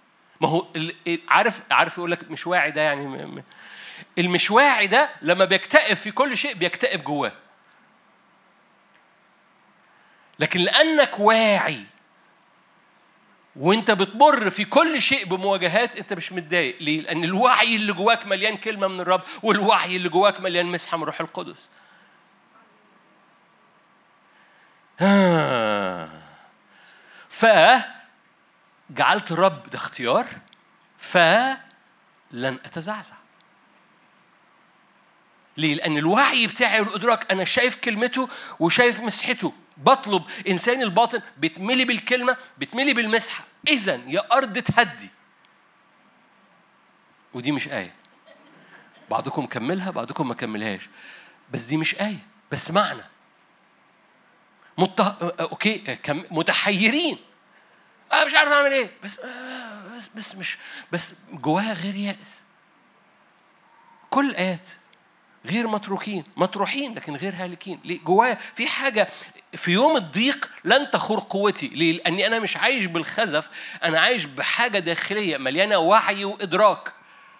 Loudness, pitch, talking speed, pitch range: -21 LUFS, 200 Hz, 105 wpm, 175-240 Hz